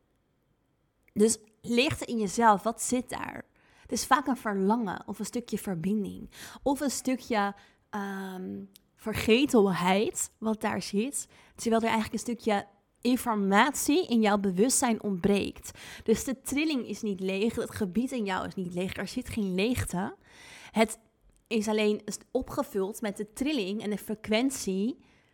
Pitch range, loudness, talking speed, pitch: 205-240 Hz, -29 LUFS, 145 wpm, 215 Hz